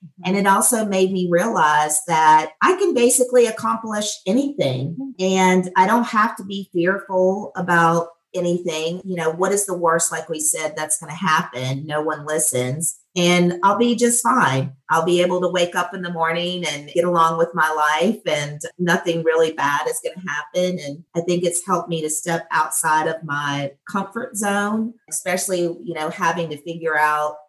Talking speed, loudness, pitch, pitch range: 185 wpm, -19 LUFS, 170 Hz, 155-190 Hz